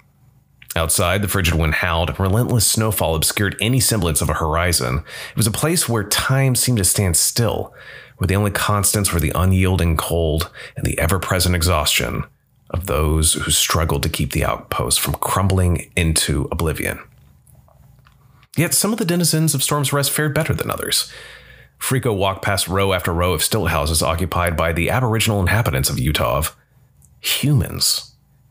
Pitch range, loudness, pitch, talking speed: 85-125 Hz, -18 LUFS, 95 Hz, 165 wpm